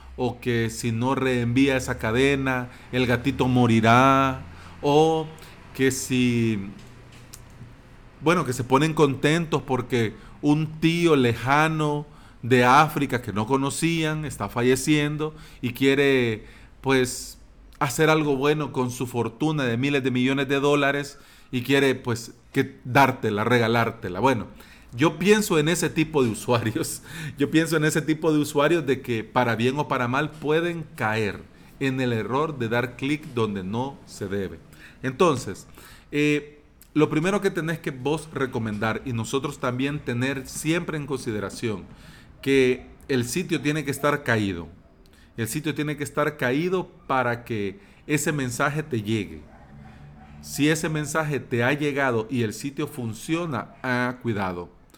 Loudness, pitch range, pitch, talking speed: -24 LUFS, 120-150 Hz, 135 Hz, 145 wpm